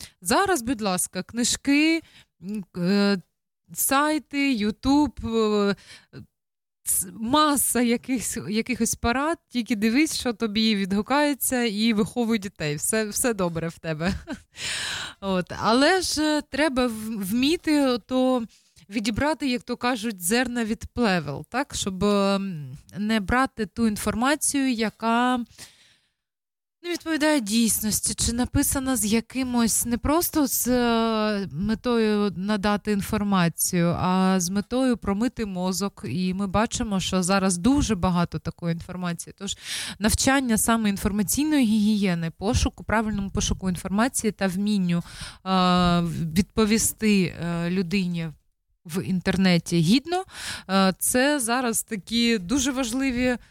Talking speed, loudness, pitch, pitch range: 105 wpm, -24 LUFS, 220 Hz, 190-250 Hz